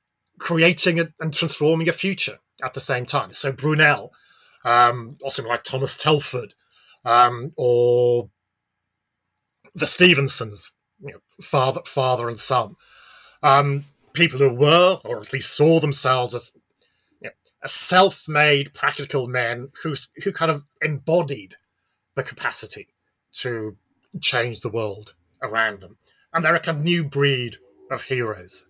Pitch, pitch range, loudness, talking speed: 135 Hz, 120-155 Hz, -20 LUFS, 130 wpm